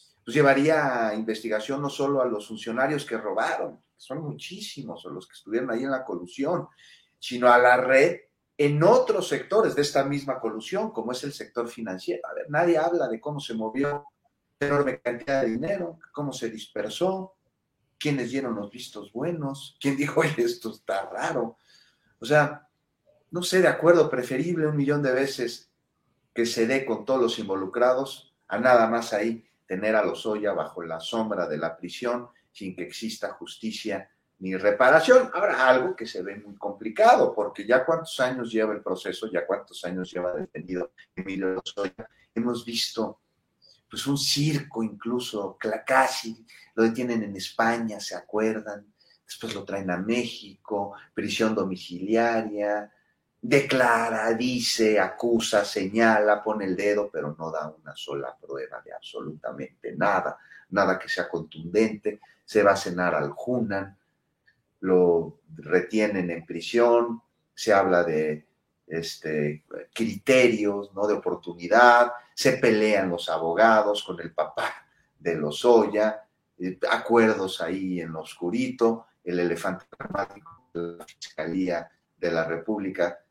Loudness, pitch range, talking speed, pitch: -25 LUFS, 95-130 Hz, 150 wpm, 115 Hz